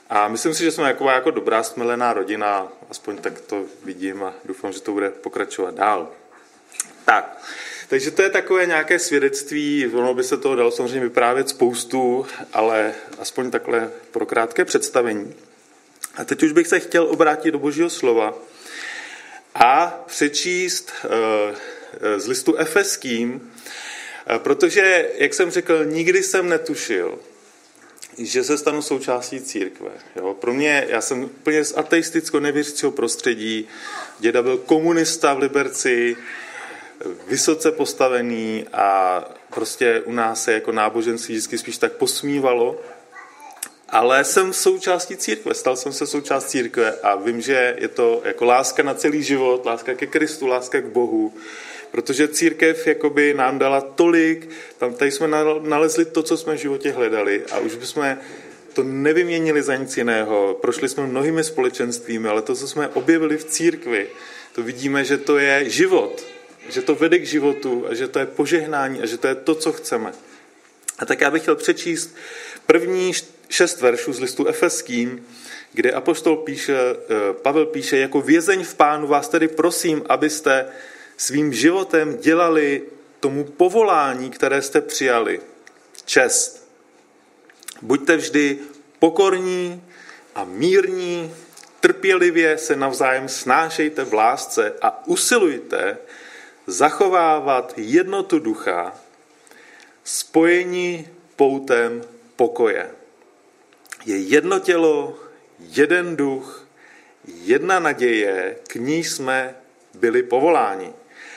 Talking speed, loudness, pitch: 130 wpm, -19 LUFS, 165 Hz